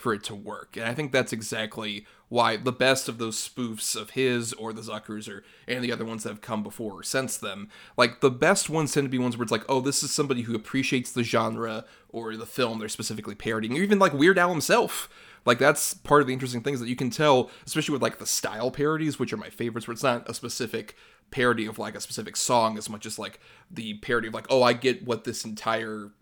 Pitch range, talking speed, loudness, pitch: 110-130 Hz, 245 wpm, -26 LUFS, 120 Hz